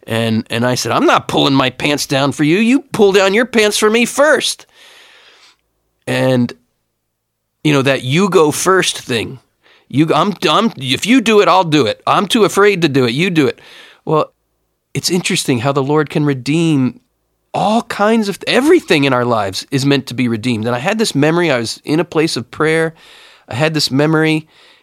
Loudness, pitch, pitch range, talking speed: -14 LUFS, 155 Hz, 130-200 Hz, 205 wpm